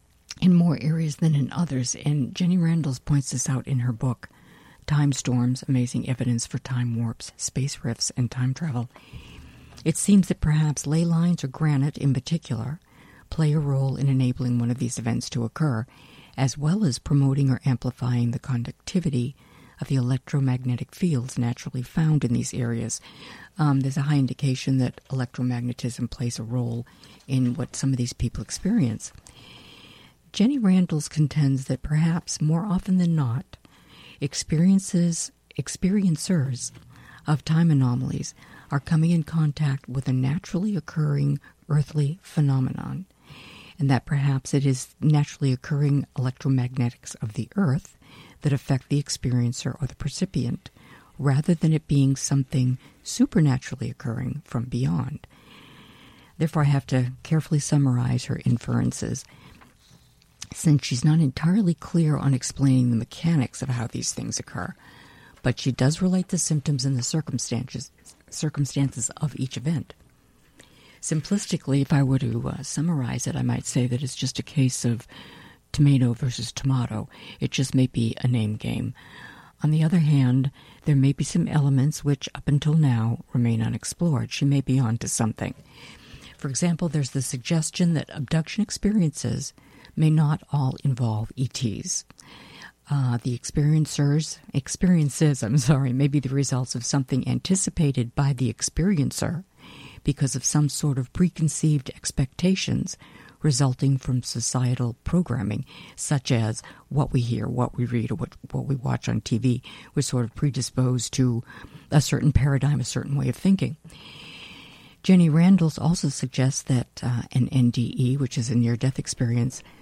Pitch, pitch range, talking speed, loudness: 135 Hz, 125-155 Hz, 150 wpm, -24 LUFS